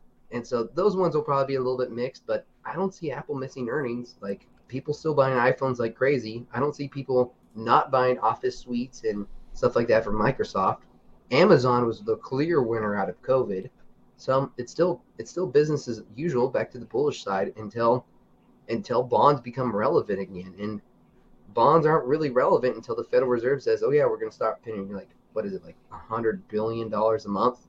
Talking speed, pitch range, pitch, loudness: 205 wpm, 115-150 Hz, 125 Hz, -26 LUFS